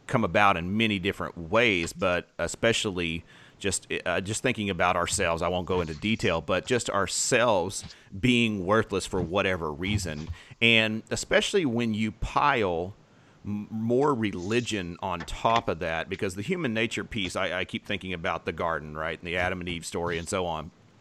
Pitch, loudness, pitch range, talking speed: 100 Hz, -27 LUFS, 85-110 Hz, 175 wpm